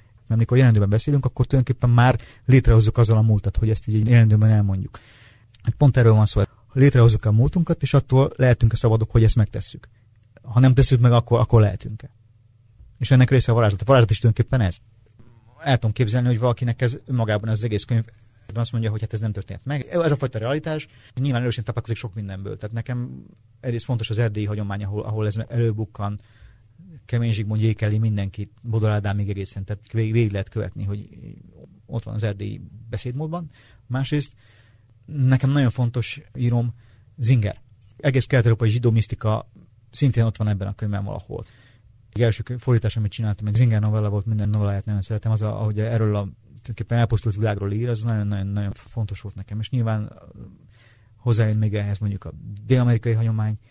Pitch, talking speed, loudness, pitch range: 115 Hz, 180 wpm, -21 LUFS, 110-120 Hz